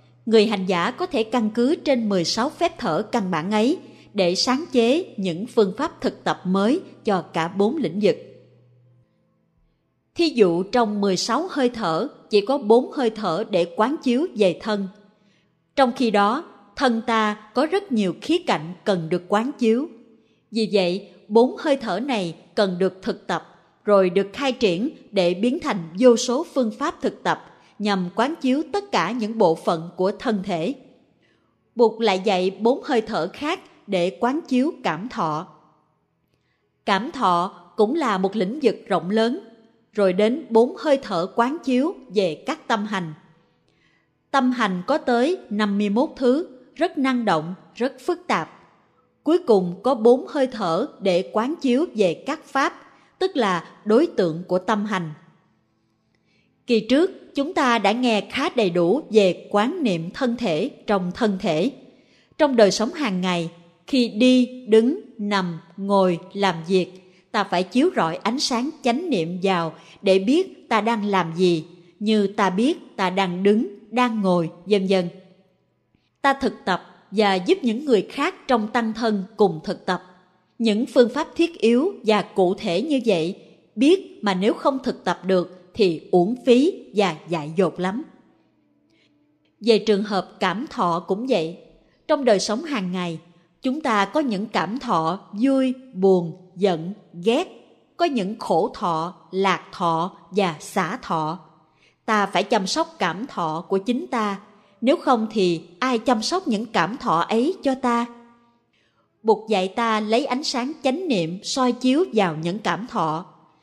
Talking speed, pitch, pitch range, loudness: 165 wpm, 215 Hz, 185-255 Hz, -22 LUFS